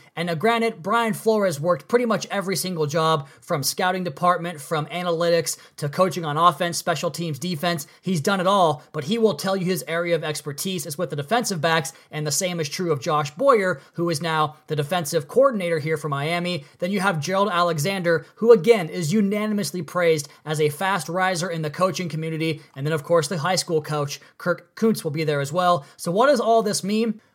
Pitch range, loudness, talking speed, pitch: 160-190 Hz, -22 LUFS, 215 wpm, 175 Hz